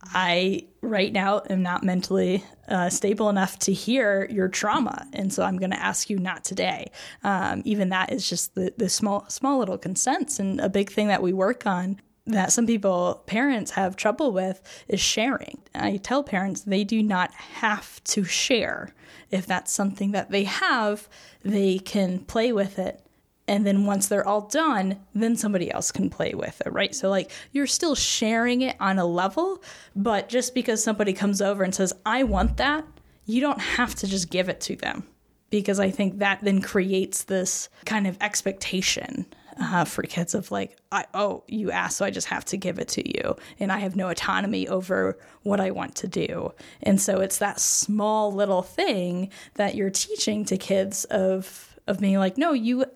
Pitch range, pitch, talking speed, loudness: 190-220 Hz, 200 Hz, 195 wpm, -25 LUFS